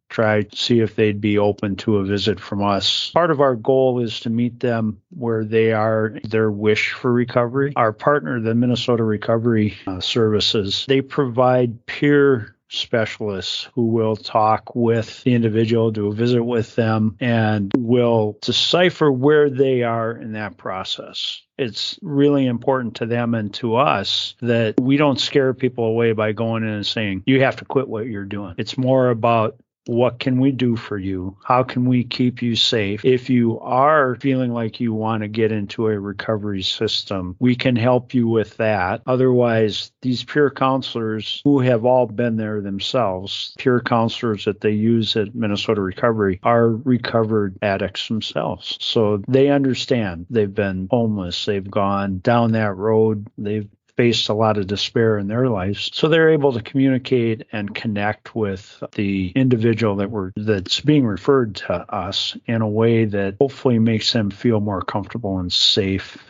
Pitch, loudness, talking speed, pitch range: 115 Hz, -19 LUFS, 170 wpm, 105-125 Hz